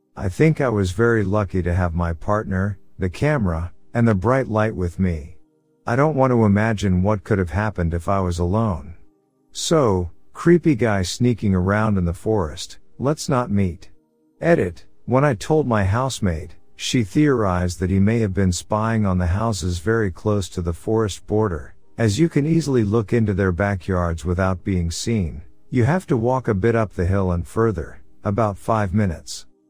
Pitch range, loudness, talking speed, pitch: 90-115 Hz, -21 LUFS, 180 wpm, 100 Hz